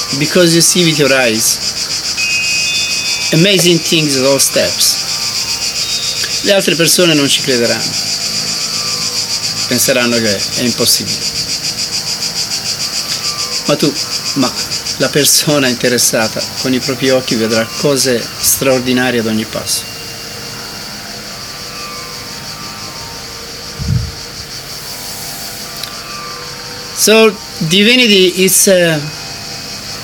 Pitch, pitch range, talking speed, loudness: 135 Hz, 120-170 Hz, 85 wpm, -11 LUFS